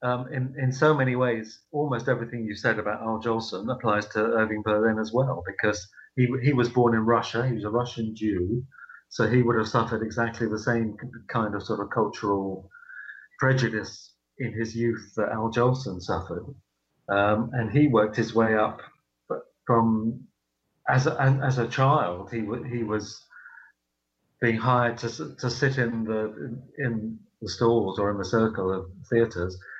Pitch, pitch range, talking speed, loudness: 115 Hz, 105-125 Hz, 170 wpm, -26 LUFS